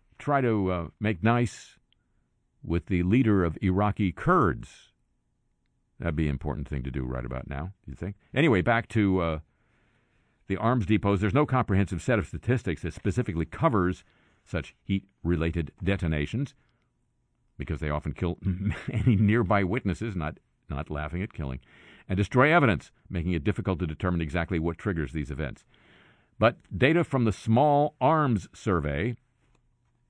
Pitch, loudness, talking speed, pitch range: 95 Hz, -27 LUFS, 150 wpm, 80-115 Hz